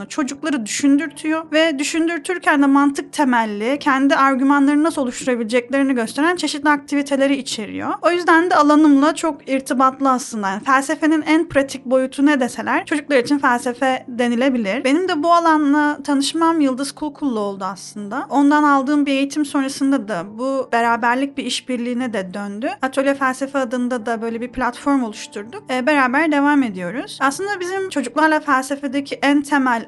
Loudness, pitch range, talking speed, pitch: -18 LUFS, 255-300 Hz, 145 wpm, 275 Hz